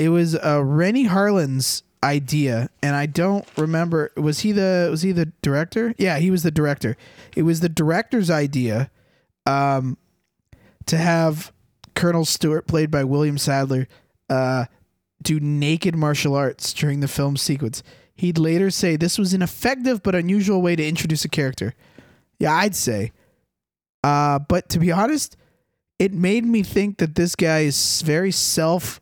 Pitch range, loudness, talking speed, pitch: 140-180 Hz, -20 LUFS, 160 wpm, 160 Hz